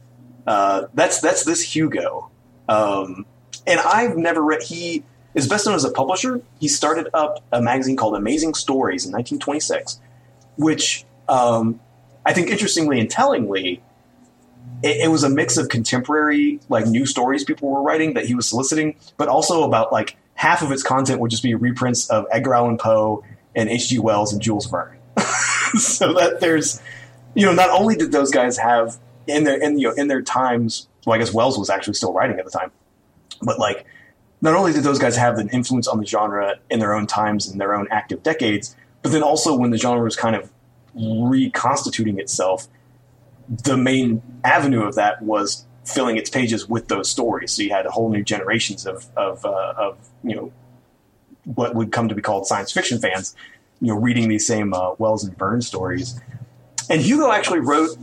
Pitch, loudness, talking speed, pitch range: 120 Hz, -19 LUFS, 190 wpm, 110-140 Hz